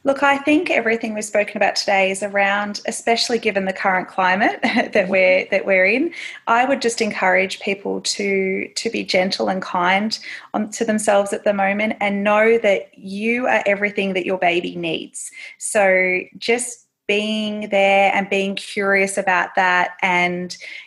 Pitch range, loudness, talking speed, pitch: 190-225 Hz, -18 LUFS, 165 wpm, 205 Hz